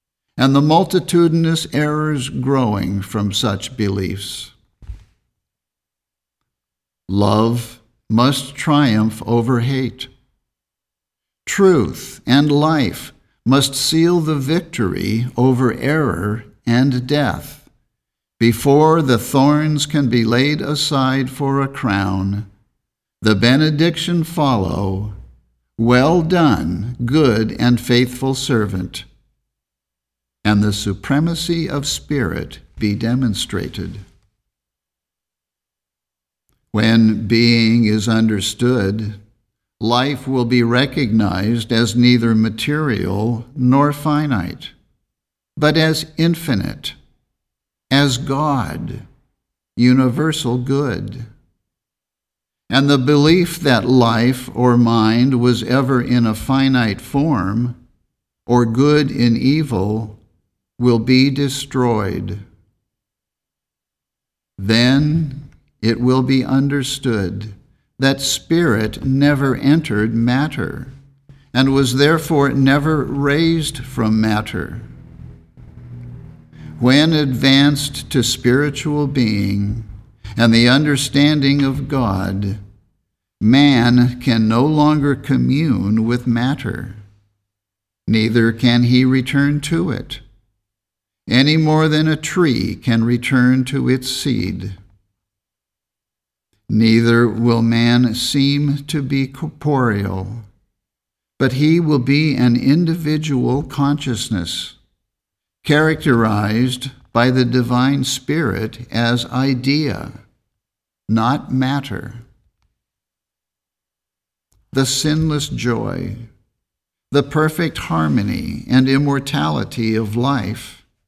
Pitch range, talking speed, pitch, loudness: 110-140 Hz, 85 wpm, 125 Hz, -16 LUFS